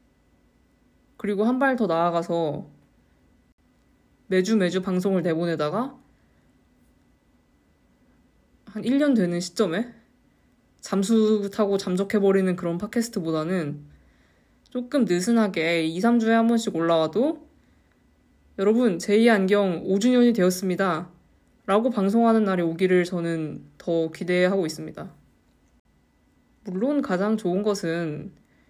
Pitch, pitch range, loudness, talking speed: 195 Hz, 170-225 Hz, -23 LUFS, 225 characters per minute